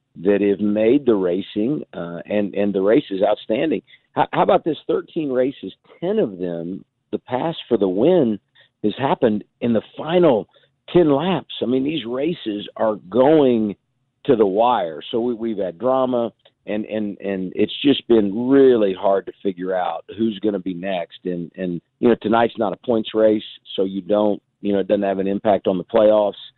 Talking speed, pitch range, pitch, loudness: 190 wpm, 100-125 Hz, 105 Hz, -20 LUFS